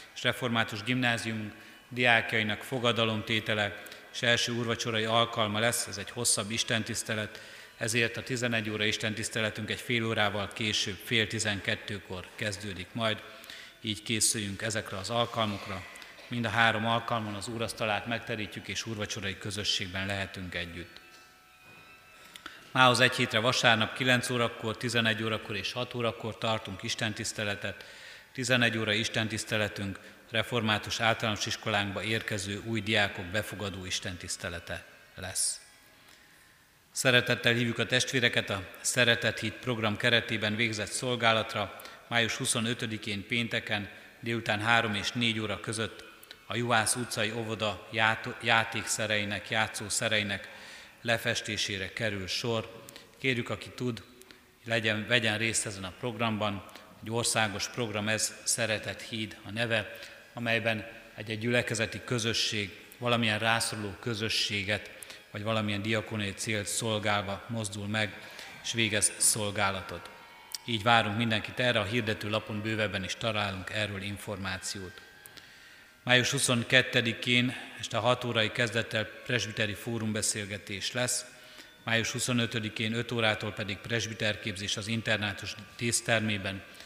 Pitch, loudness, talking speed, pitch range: 110 Hz, -30 LUFS, 115 wpm, 105-115 Hz